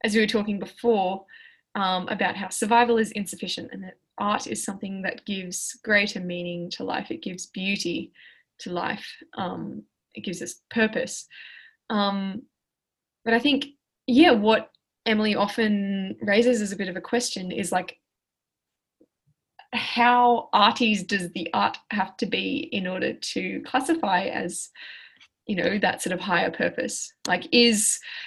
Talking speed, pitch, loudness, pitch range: 150 wpm, 215 Hz, -24 LUFS, 195-240 Hz